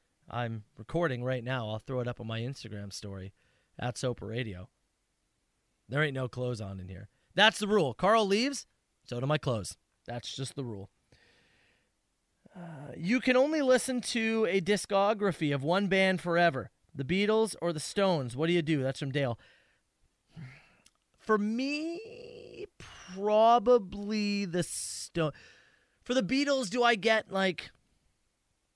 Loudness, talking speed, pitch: -30 LUFS, 150 wpm, 170 Hz